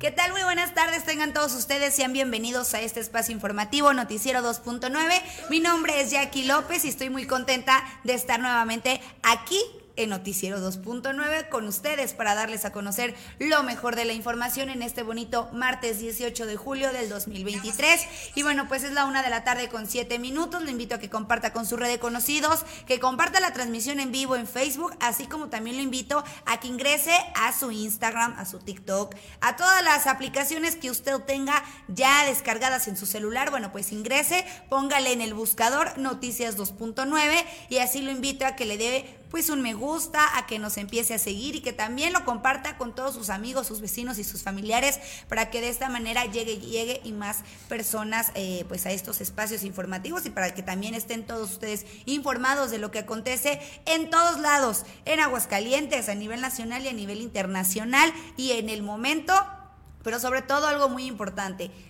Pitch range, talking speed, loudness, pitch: 225-285 Hz, 190 wpm, -26 LUFS, 250 Hz